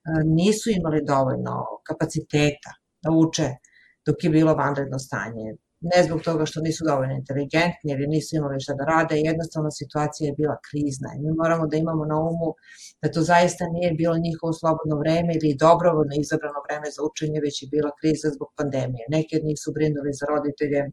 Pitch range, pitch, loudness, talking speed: 145-160 Hz, 155 Hz, -23 LUFS, 180 wpm